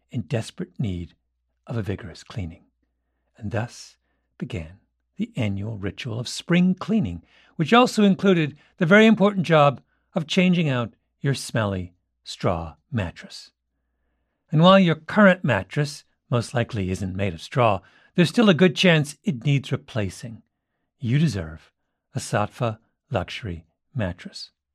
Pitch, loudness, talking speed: 120 Hz, -22 LUFS, 135 wpm